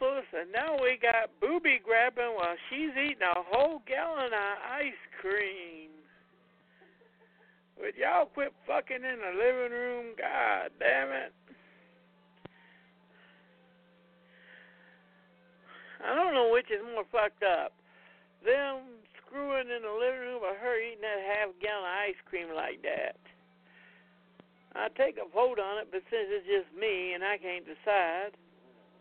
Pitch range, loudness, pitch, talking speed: 180-270 Hz, -31 LUFS, 225 Hz, 135 wpm